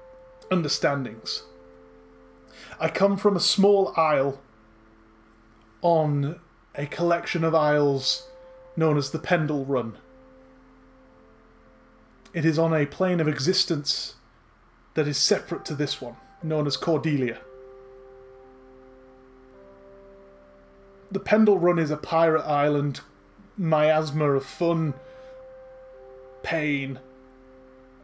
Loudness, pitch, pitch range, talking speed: -24 LUFS, 145 Hz, 120-165 Hz, 95 wpm